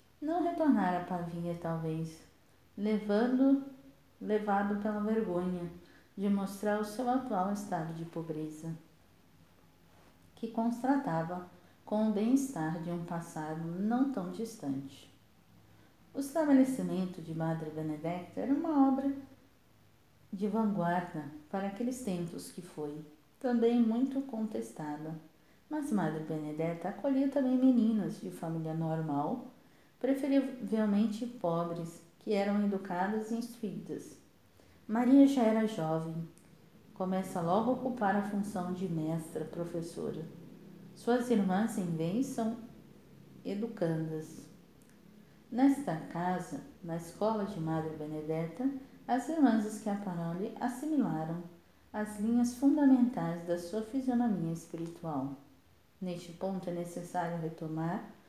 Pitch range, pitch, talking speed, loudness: 165-230 Hz, 190 Hz, 110 wpm, -33 LUFS